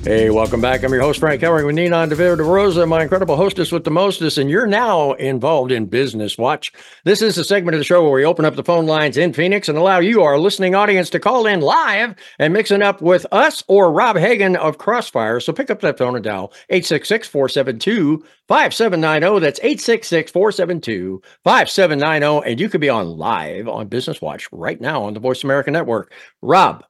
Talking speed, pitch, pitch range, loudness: 200 wpm, 160 Hz, 140-185 Hz, -16 LUFS